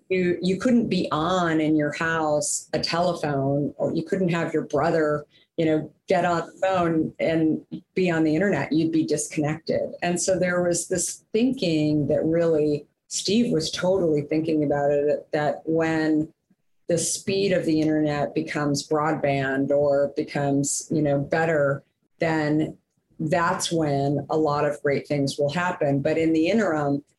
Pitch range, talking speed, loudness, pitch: 145-170 Hz, 160 wpm, -24 LUFS, 155 Hz